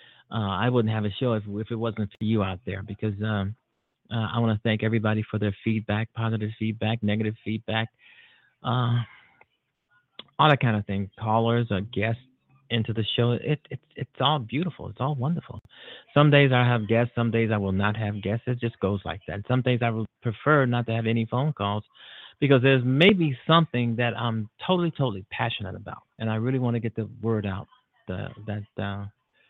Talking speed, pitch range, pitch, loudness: 200 wpm, 105-125 Hz, 115 Hz, -26 LUFS